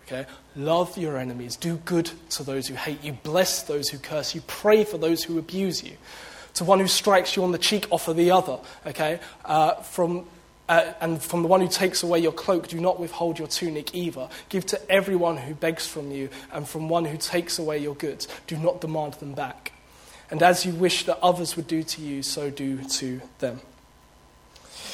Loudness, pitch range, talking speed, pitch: -25 LUFS, 145-175 Hz, 205 wpm, 165 Hz